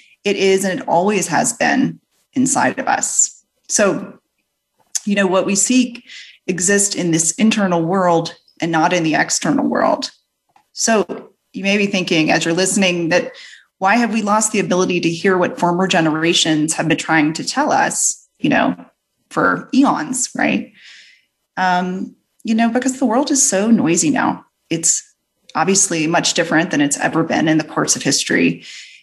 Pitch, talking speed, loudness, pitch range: 190 Hz, 165 wpm, -16 LUFS, 165-225 Hz